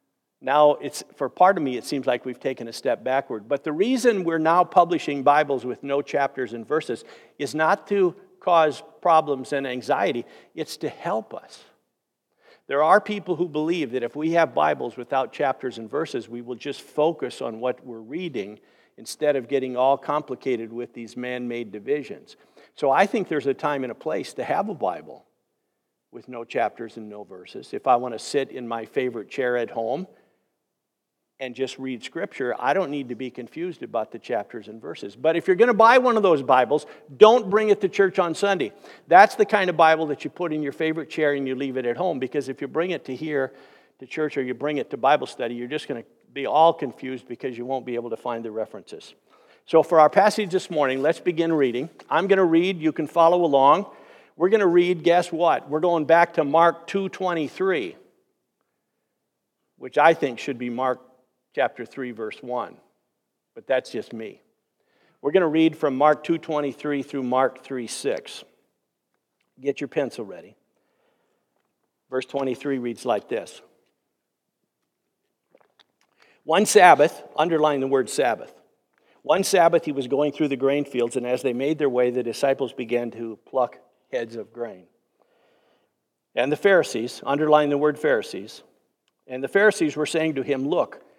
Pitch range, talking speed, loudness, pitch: 130-165 Hz, 190 wpm, -23 LUFS, 145 Hz